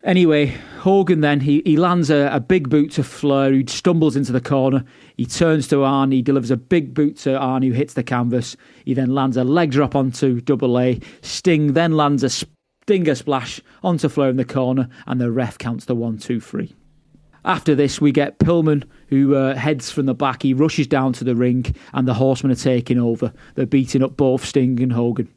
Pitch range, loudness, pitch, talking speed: 130-150 Hz, -18 LUFS, 135 Hz, 215 wpm